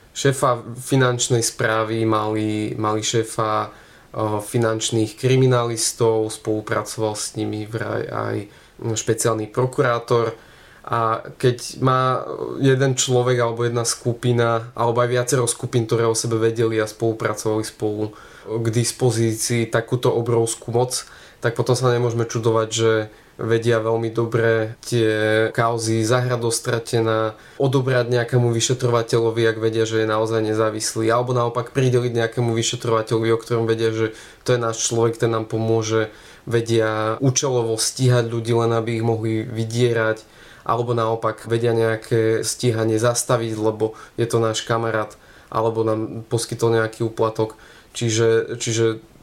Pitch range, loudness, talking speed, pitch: 110-120 Hz, -21 LUFS, 125 wpm, 115 Hz